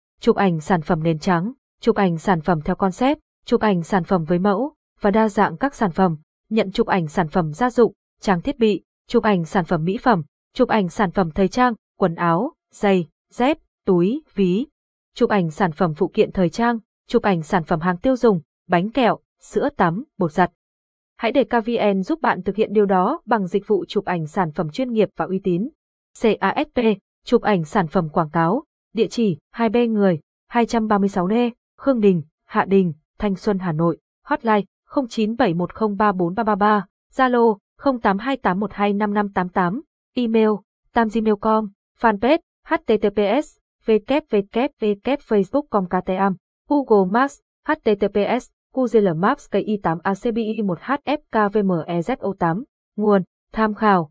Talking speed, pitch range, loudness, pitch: 155 wpm, 190-235 Hz, -20 LUFS, 210 Hz